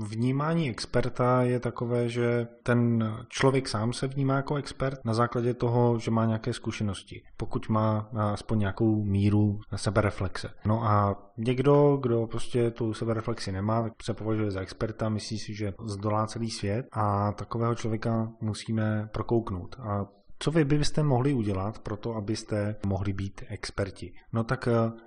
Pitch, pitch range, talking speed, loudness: 115 Hz, 105-120 Hz, 150 wpm, -29 LUFS